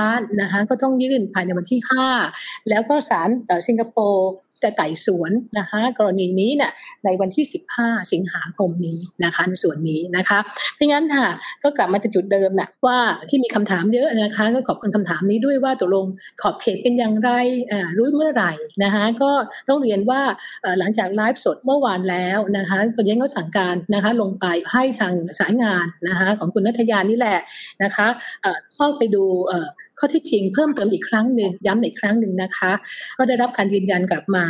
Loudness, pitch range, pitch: -19 LUFS, 190-250 Hz, 215 Hz